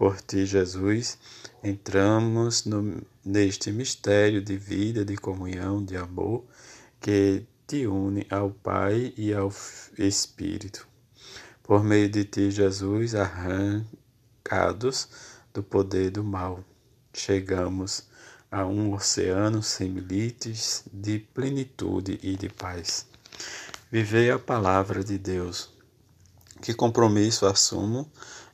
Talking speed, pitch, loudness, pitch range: 105 wpm, 100 Hz, -26 LUFS, 95-110 Hz